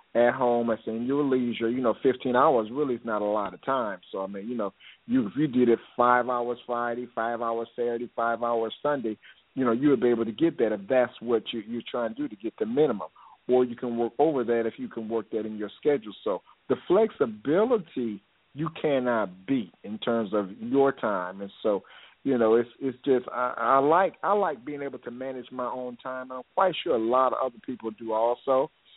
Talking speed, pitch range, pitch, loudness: 230 wpm, 115-135 Hz, 120 Hz, -27 LUFS